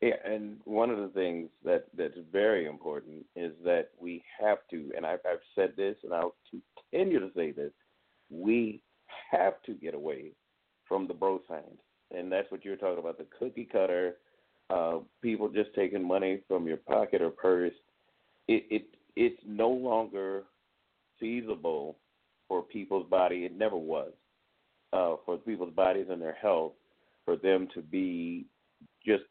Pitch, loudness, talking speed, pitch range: 100 Hz, -32 LUFS, 160 wpm, 90-130 Hz